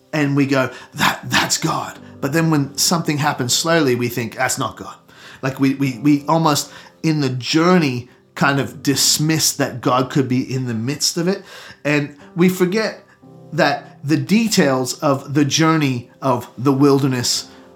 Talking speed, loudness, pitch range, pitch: 165 wpm, -18 LUFS, 130-160 Hz, 140 Hz